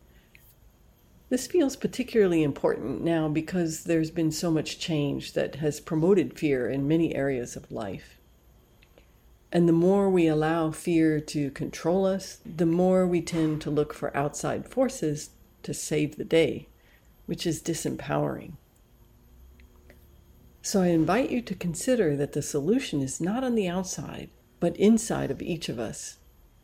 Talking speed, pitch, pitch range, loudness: 145 wpm, 160 Hz, 150-185 Hz, -27 LUFS